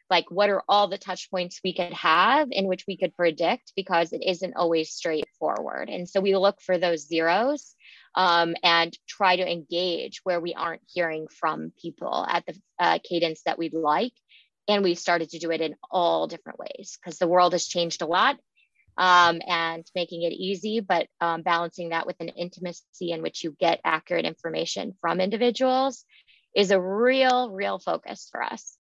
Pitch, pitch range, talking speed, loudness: 180 Hz, 170-195 Hz, 185 wpm, -25 LUFS